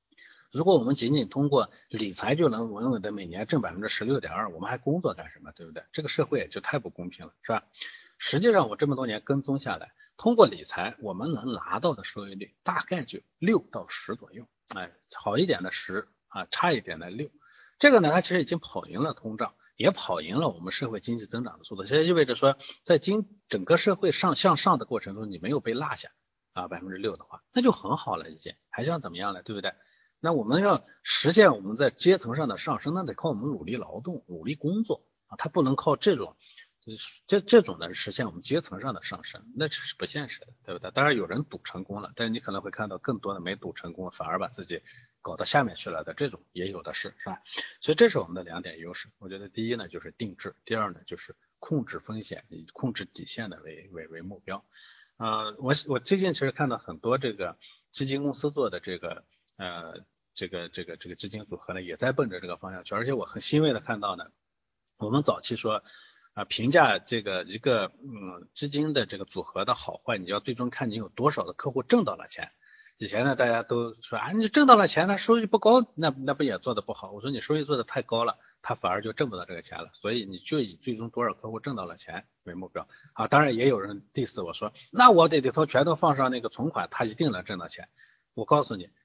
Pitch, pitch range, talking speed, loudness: 130 Hz, 105-155 Hz, 340 characters per minute, -27 LUFS